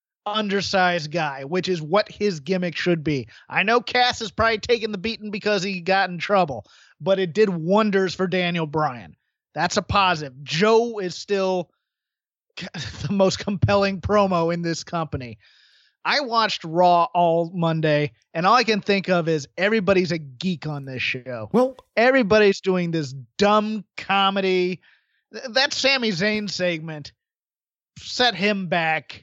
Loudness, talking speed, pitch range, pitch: -21 LUFS, 150 wpm, 165-210 Hz, 185 Hz